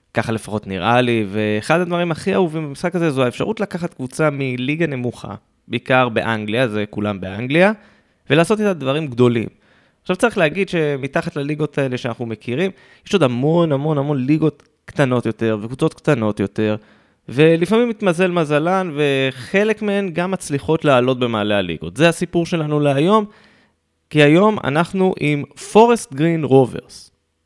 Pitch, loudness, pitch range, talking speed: 145 Hz, -18 LUFS, 120-175 Hz, 140 wpm